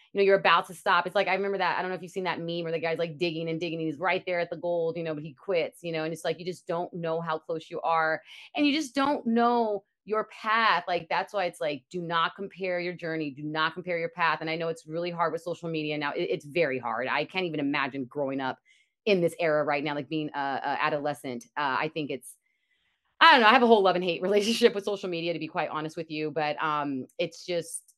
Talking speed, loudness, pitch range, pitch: 280 wpm, -28 LUFS, 155-185 Hz, 170 Hz